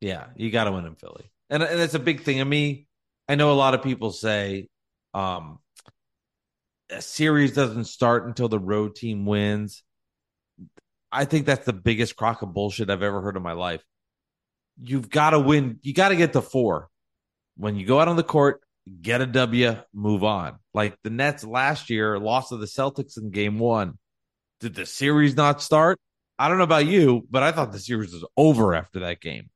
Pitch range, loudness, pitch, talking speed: 105-140 Hz, -23 LUFS, 120 Hz, 205 wpm